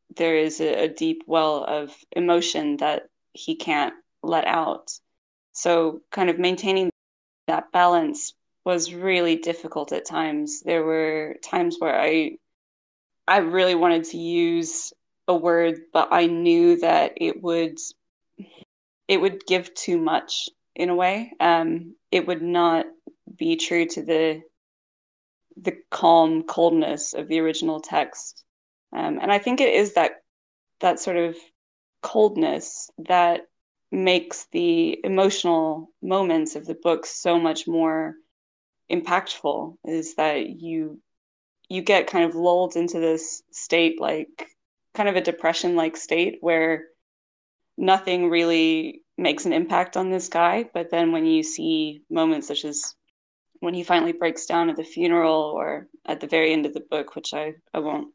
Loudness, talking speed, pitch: -23 LUFS, 145 wpm, 175 Hz